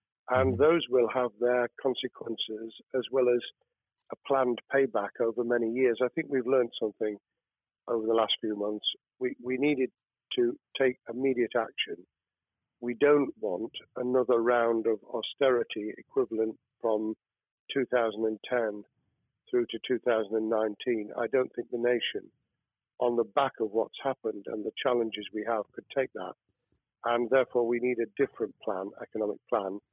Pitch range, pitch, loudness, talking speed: 110-125 Hz, 120 Hz, -30 LUFS, 145 wpm